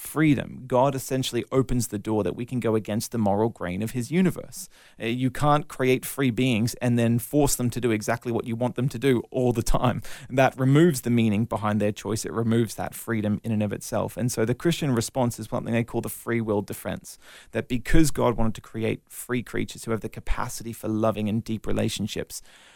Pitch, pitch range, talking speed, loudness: 115 Hz, 110-125 Hz, 220 wpm, -26 LUFS